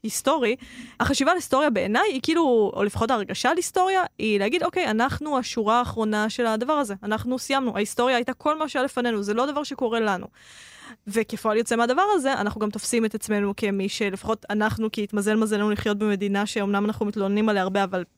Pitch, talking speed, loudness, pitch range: 225 Hz, 190 wpm, -24 LUFS, 210-255 Hz